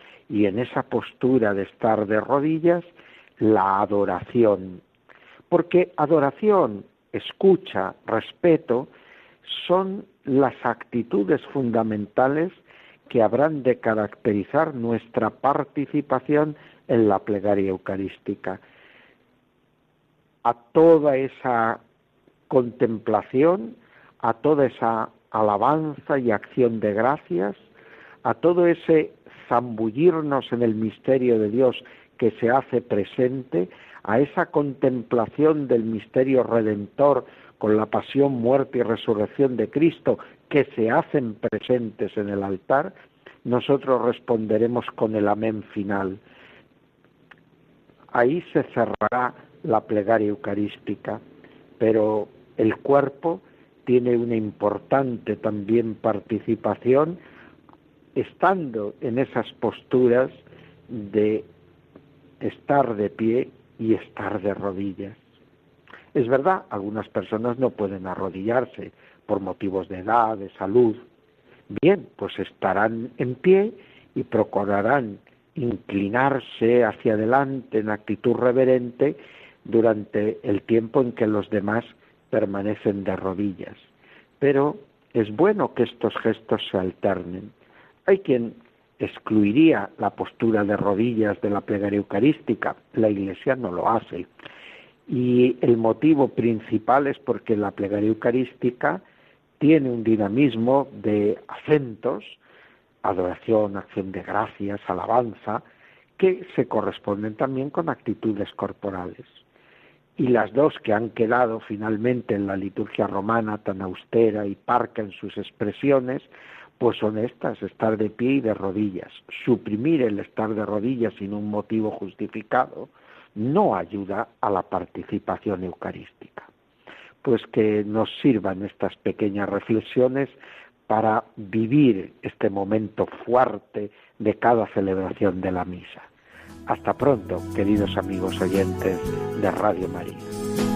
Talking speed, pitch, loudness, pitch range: 110 wpm, 110 Hz, -23 LUFS, 105-130 Hz